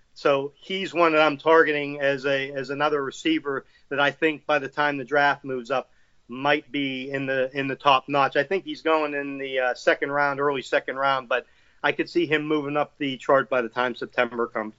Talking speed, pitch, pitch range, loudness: 225 wpm, 140 Hz, 135-150 Hz, -24 LUFS